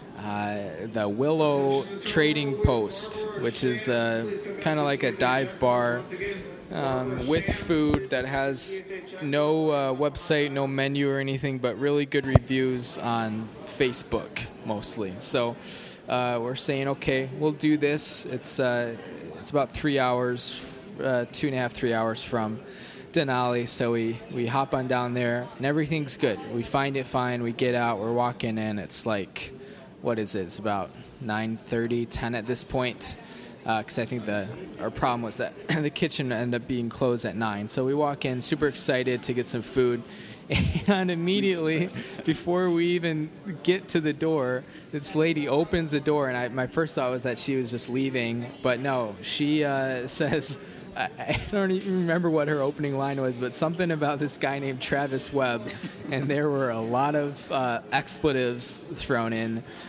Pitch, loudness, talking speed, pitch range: 135 Hz, -27 LUFS, 175 wpm, 120-150 Hz